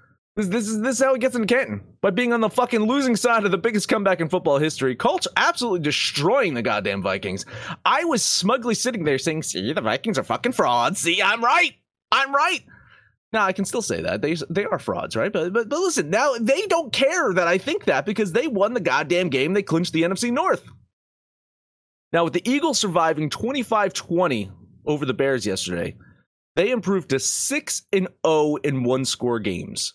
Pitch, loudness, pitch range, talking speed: 200 Hz, -21 LUFS, 160-250 Hz, 200 wpm